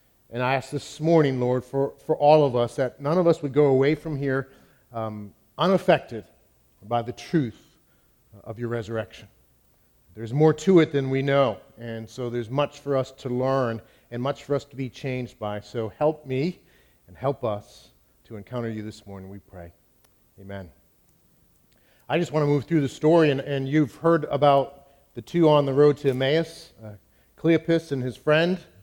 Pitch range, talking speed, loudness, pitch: 115-150 Hz, 185 wpm, -24 LUFS, 135 Hz